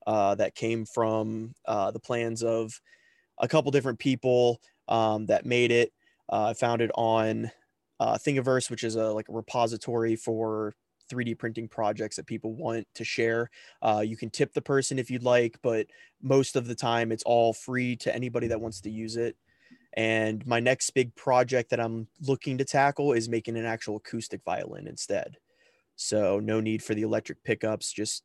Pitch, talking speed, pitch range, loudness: 115 Hz, 185 wpm, 110-125 Hz, -28 LUFS